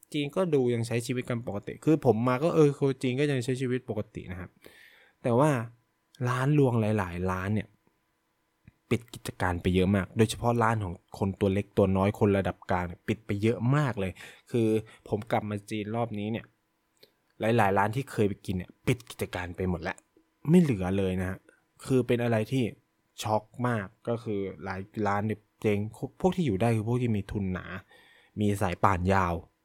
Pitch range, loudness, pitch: 100-125 Hz, -29 LUFS, 110 Hz